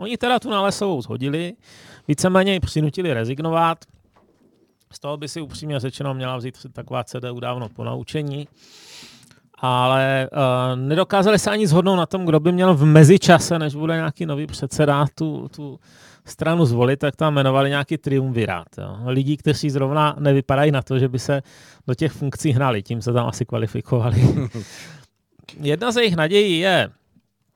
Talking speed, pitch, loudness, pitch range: 155 wpm, 145 Hz, -19 LUFS, 130-160 Hz